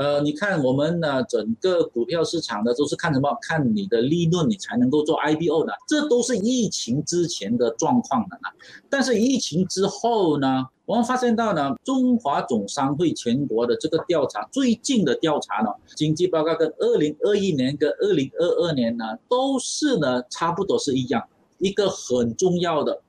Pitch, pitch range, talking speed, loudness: 175 Hz, 150-235 Hz, 280 characters per minute, -22 LUFS